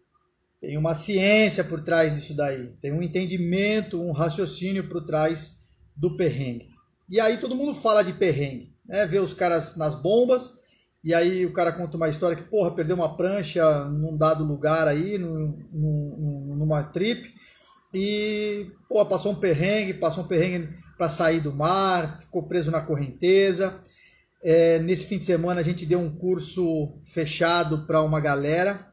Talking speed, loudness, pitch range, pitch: 160 wpm, -24 LUFS, 155-190 Hz, 170 Hz